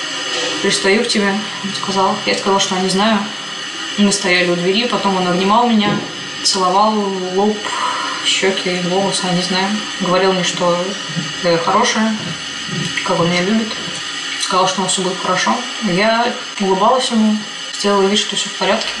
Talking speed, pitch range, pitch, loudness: 160 wpm, 185-205 Hz, 195 Hz, -16 LUFS